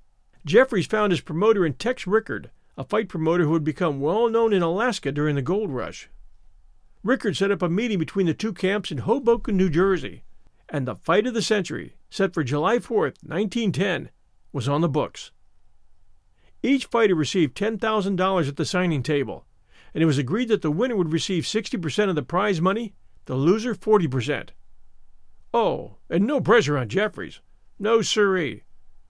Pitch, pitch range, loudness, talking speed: 185 Hz, 155-215 Hz, -23 LUFS, 170 wpm